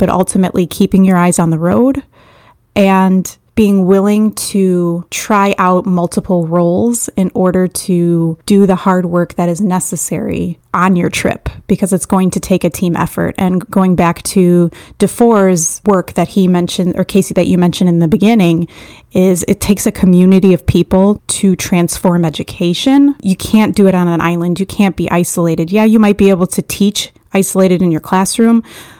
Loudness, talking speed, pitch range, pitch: -12 LUFS, 180 wpm, 175-200 Hz, 185 Hz